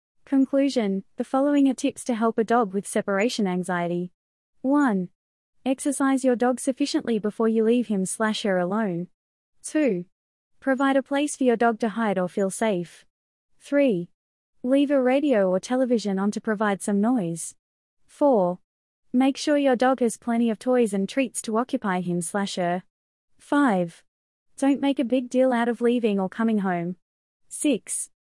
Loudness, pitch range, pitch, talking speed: -24 LUFS, 195-265 Hz, 230 Hz, 150 wpm